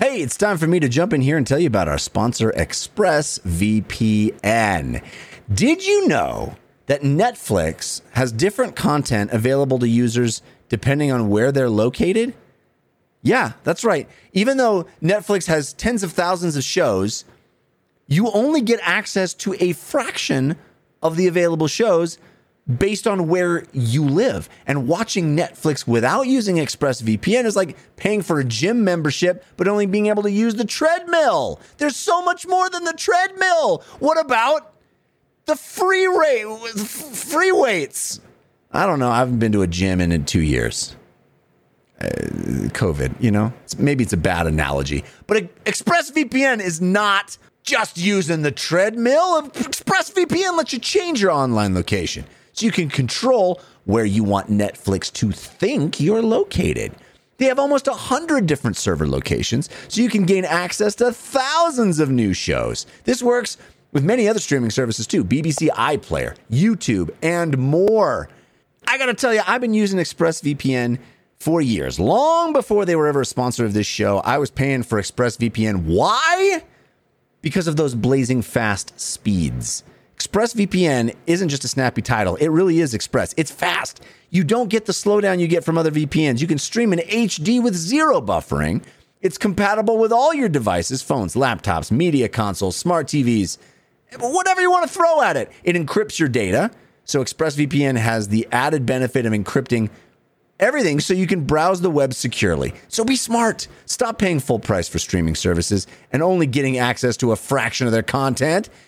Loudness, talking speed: -19 LUFS, 165 wpm